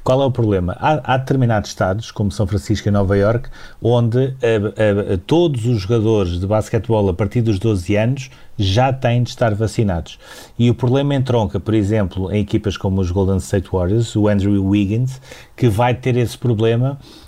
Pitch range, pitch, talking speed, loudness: 100-125 Hz, 110 Hz, 190 wpm, -17 LUFS